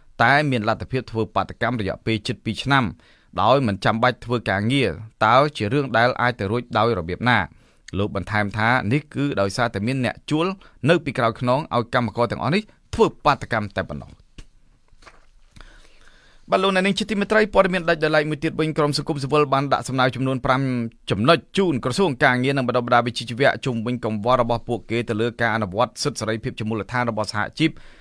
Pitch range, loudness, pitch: 110-140 Hz, -21 LUFS, 125 Hz